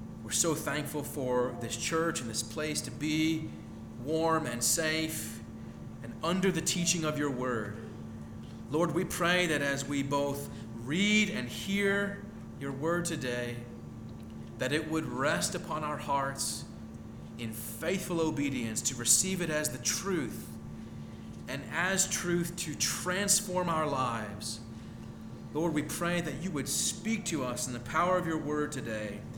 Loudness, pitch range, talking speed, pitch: -31 LUFS, 120-170 Hz, 150 wpm, 150 Hz